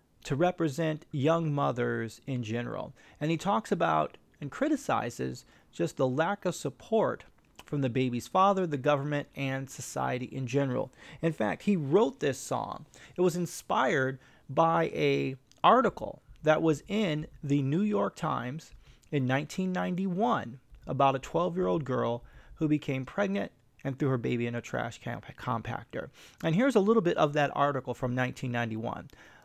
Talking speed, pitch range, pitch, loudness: 155 wpm, 125-165 Hz, 145 Hz, -30 LUFS